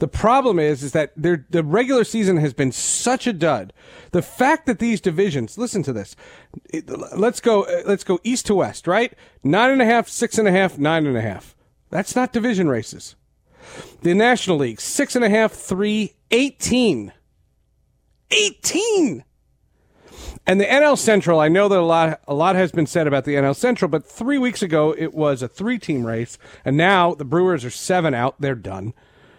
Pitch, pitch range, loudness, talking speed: 185 Hz, 145-230 Hz, -19 LUFS, 195 wpm